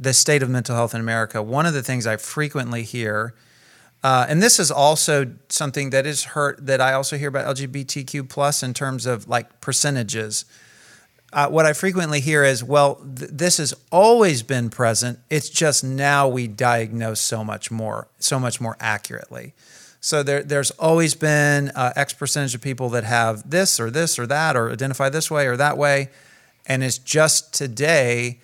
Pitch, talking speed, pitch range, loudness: 135 Hz, 185 wpm, 120-145 Hz, -20 LUFS